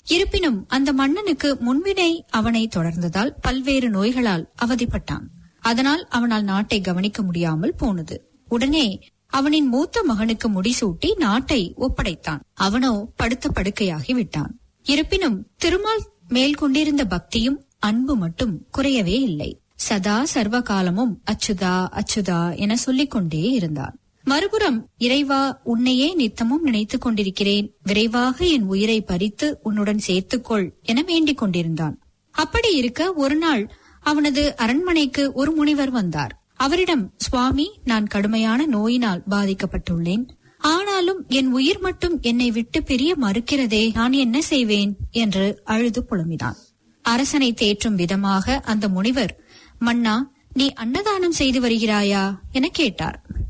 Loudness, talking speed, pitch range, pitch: -21 LUFS, 110 wpm, 205-280 Hz, 240 Hz